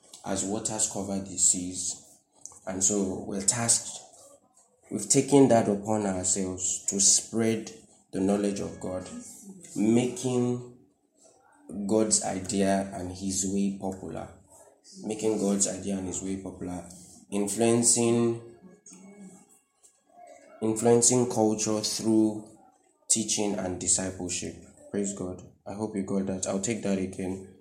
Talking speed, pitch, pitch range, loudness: 115 wpm, 100 Hz, 95-115 Hz, -26 LUFS